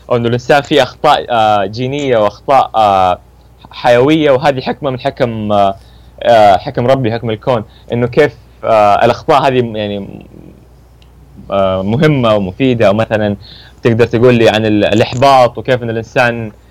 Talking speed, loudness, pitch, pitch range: 110 wpm, -11 LUFS, 115 Hz, 100-130 Hz